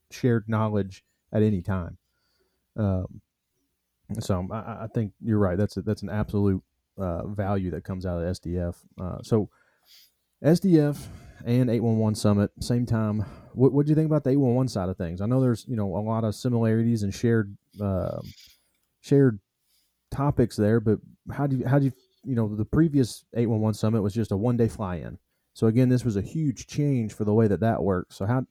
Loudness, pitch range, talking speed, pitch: -26 LUFS, 95-120 Hz, 205 wpm, 110 Hz